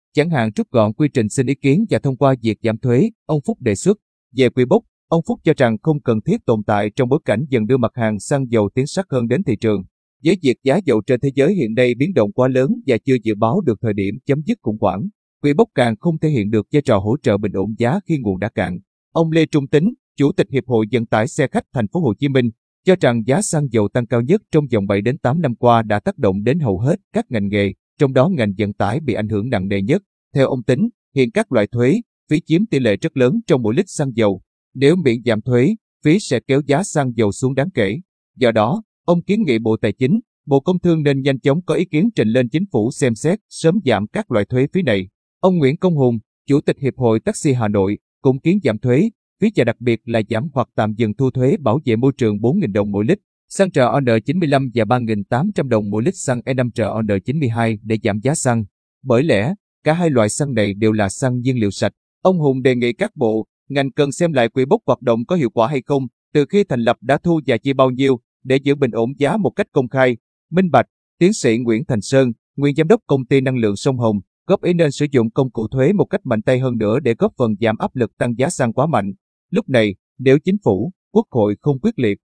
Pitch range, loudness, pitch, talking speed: 110-155 Hz, -18 LUFS, 130 Hz, 255 wpm